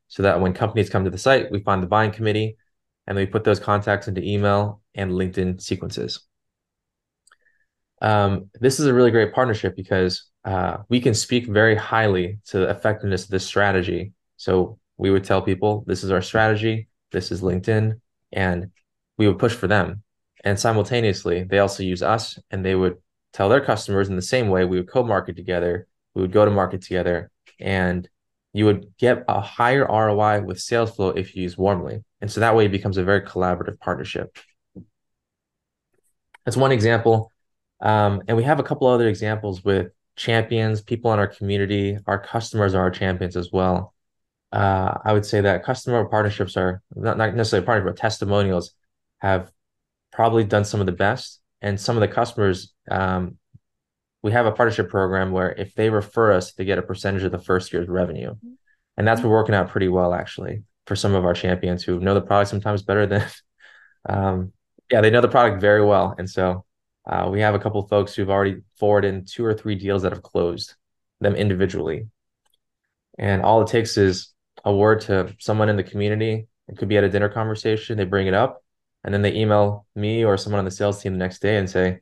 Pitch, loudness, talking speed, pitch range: 100 Hz, -21 LUFS, 200 wpm, 95-110 Hz